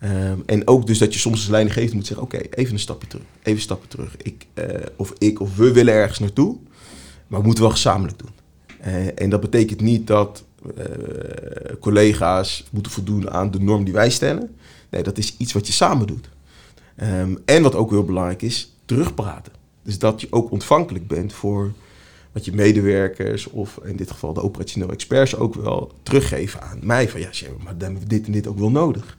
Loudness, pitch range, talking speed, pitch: -20 LUFS, 95-110 Hz, 210 wpm, 105 Hz